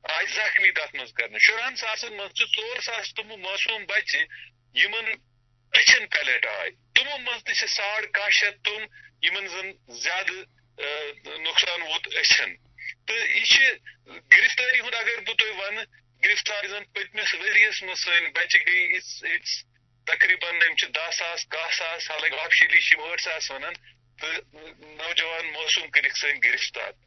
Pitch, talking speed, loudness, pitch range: 190 Hz, 110 wpm, -22 LUFS, 150-220 Hz